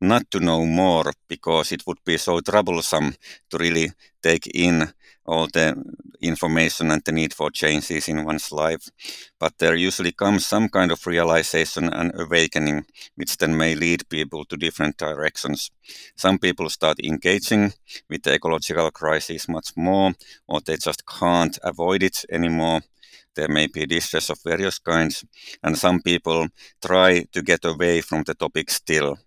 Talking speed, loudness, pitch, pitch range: 160 wpm, -21 LUFS, 80 Hz, 80-90 Hz